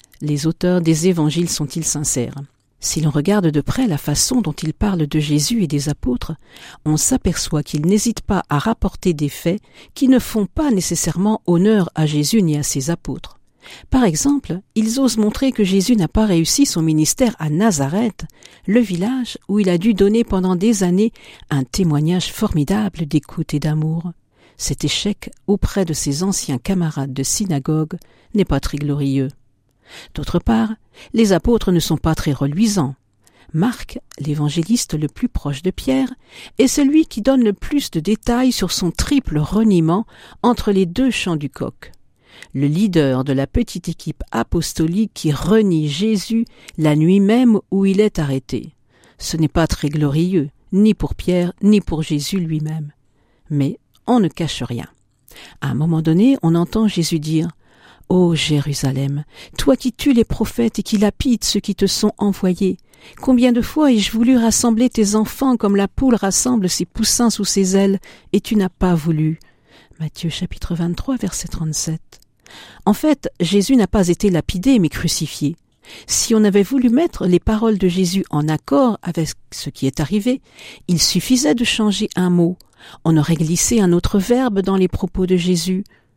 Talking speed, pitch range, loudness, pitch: 175 wpm, 155-215 Hz, -17 LUFS, 180 Hz